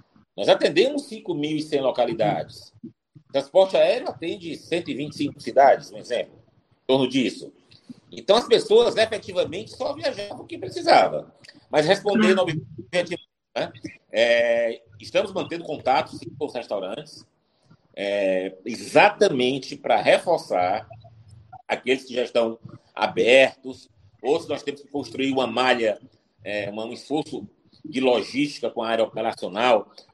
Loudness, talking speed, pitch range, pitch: -23 LUFS, 125 wpm, 115-175 Hz, 130 Hz